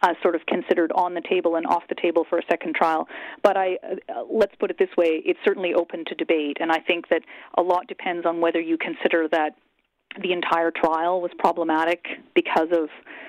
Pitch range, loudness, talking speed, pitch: 165-180 Hz, -23 LUFS, 210 wpm, 170 Hz